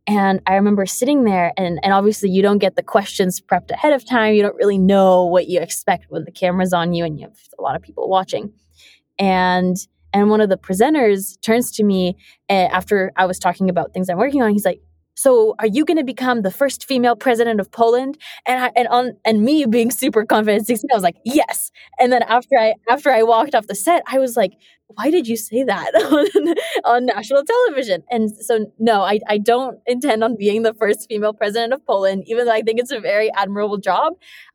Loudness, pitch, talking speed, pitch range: -17 LUFS, 215 Hz, 220 wpm, 190-245 Hz